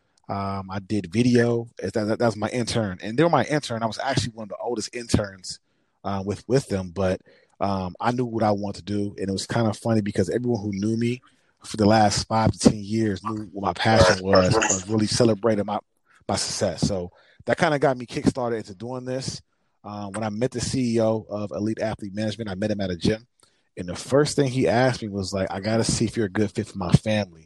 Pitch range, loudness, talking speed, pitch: 100-120 Hz, -24 LUFS, 245 wpm, 110 Hz